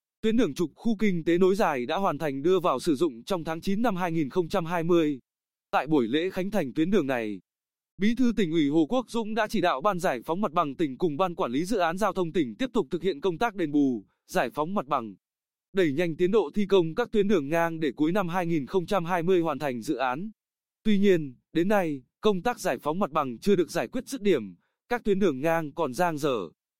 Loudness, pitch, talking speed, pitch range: -27 LUFS, 185 Hz, 235 wpm, 160-210 Hz